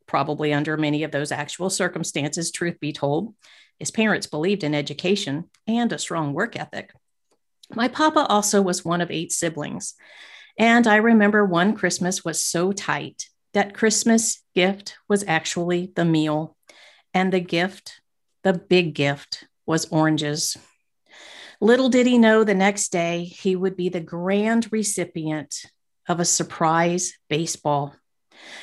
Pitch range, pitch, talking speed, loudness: 160-205 Hz, 180 Hz, 145 wpm, -22 LUFS